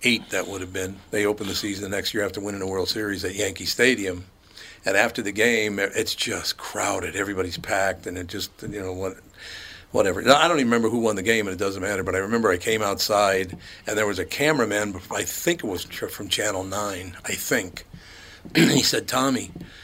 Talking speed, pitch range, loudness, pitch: 215 wpm, 95-105 Hz, -24 LUFS, 100 Hz